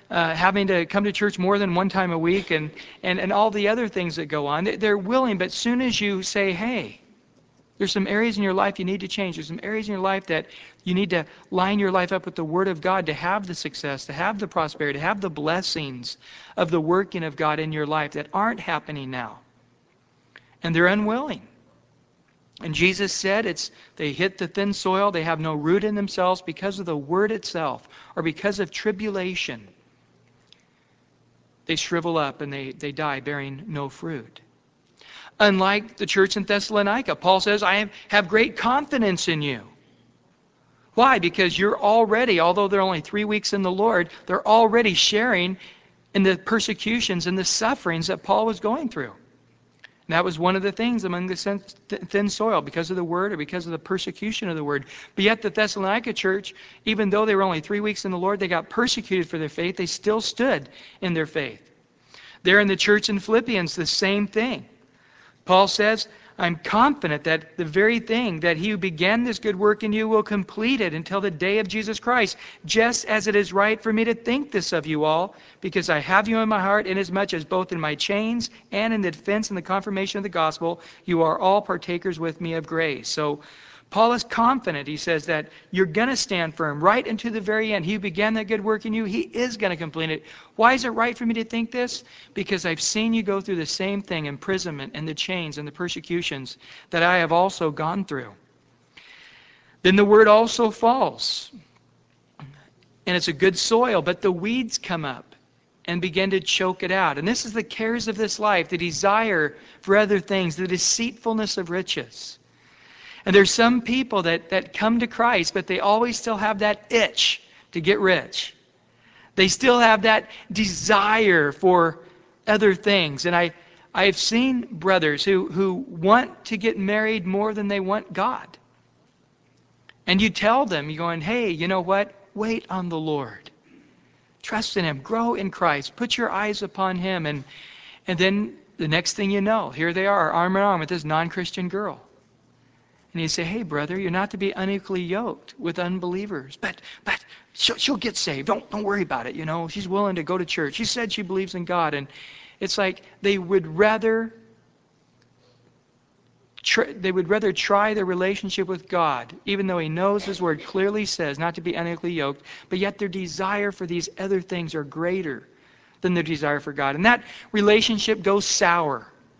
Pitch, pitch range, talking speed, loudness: 190 Hz, 170-210 Hz, 200 wpm, -23 LUFS